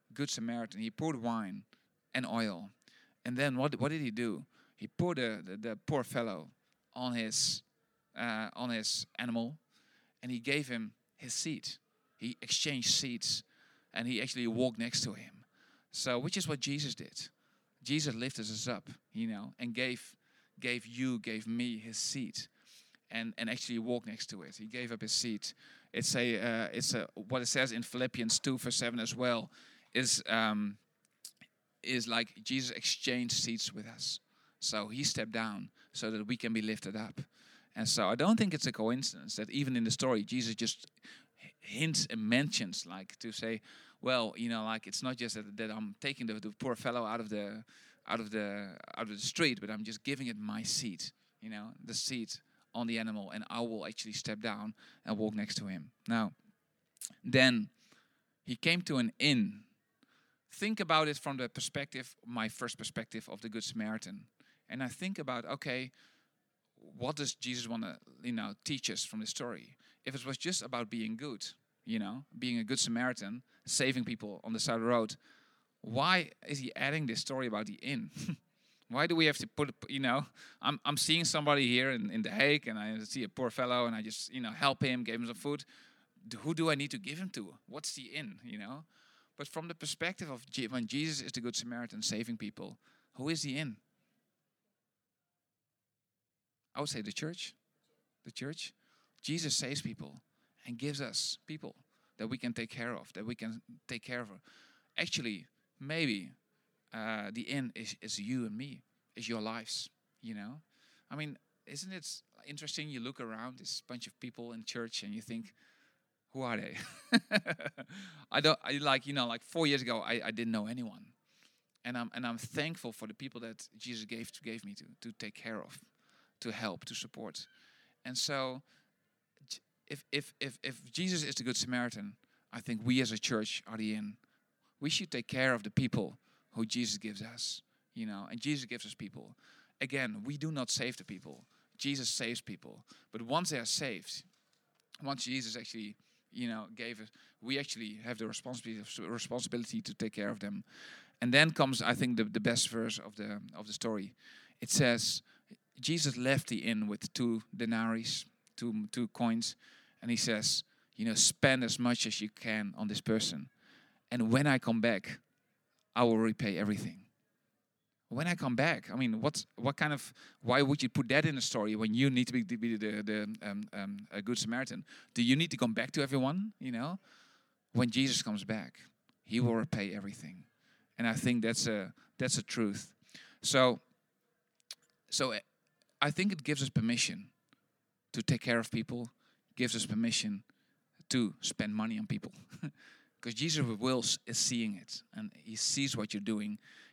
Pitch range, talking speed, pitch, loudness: 115-145 Hz, 190 wpm, 125 Hz, -35 LUFS